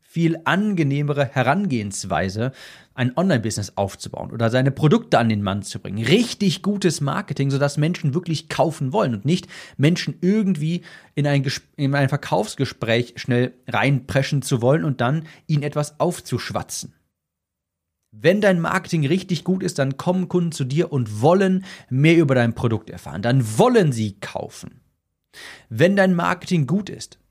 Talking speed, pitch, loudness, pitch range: 155 wpm, 145 Hz, -21 LUFS, 120-170 Hz